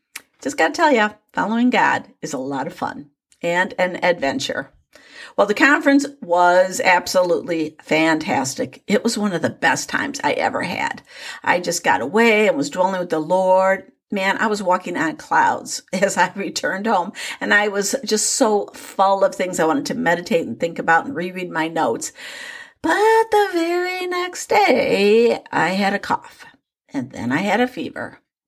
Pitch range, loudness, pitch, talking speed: 180-265 Hz, -19 LUFS, 200 Hz, 180 wpm